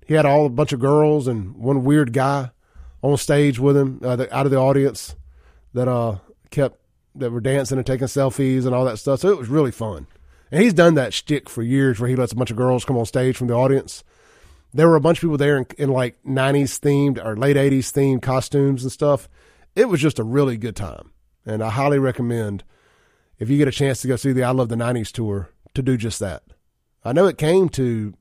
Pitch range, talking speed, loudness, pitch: 115-140 Hz, 240 wpm, -19 LUFS, 130 Hz